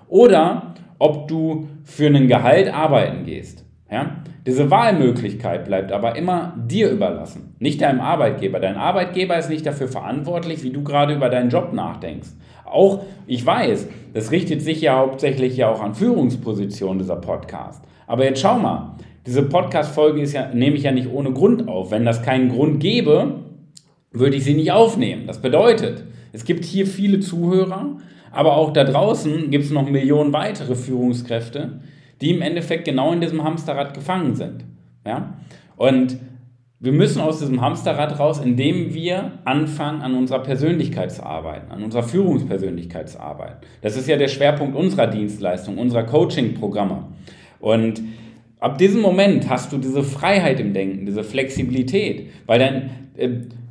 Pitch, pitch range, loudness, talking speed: 140 Hz, 125-160 Hz, -19 LUFS, 160 wpm